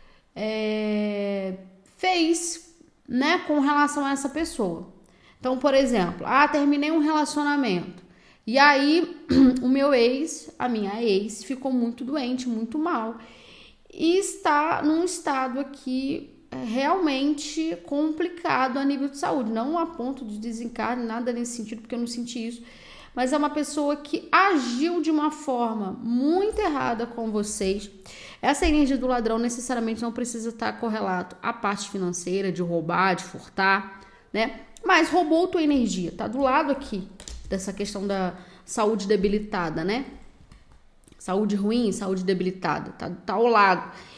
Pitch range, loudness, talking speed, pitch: 205-295 Hz, -25 LUFS, 145 wpm, 245 Hz